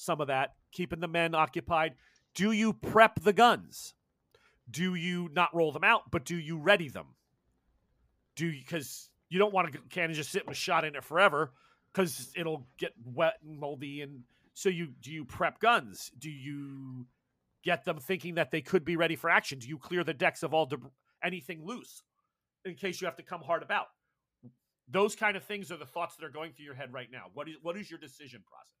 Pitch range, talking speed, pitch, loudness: 145-180 Hz, 215 wpm, 165 Hz, -31 LUFS